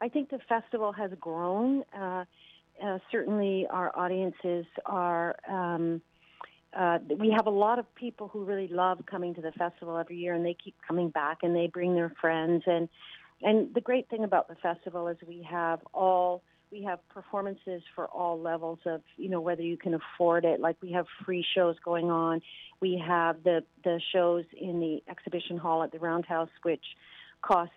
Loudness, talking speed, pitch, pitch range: -31 LUFS, 185 wpm, 175 Hz, 170-190 Hz